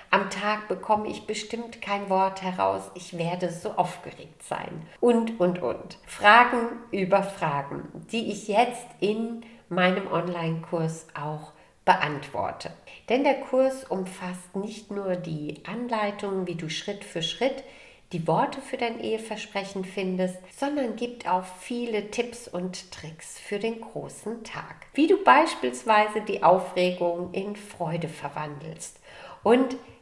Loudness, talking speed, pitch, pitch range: -26 LUFS, 130 wpm, 195 Hz, 175-230 Hz